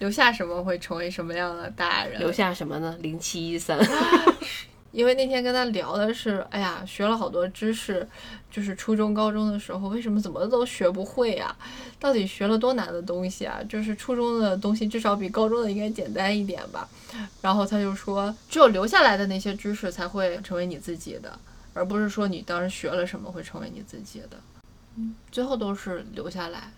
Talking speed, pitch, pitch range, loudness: 305 characters per minute, 200 Hz, 180-220 Hz, -26 LUFS